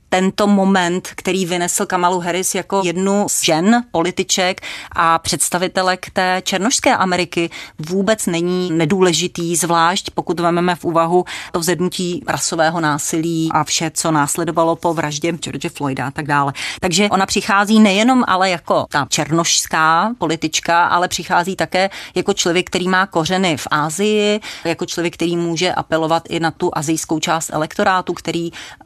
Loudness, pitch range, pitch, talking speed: -16 LUFS, 165-185 Hz, 175 Hz, 145 wpm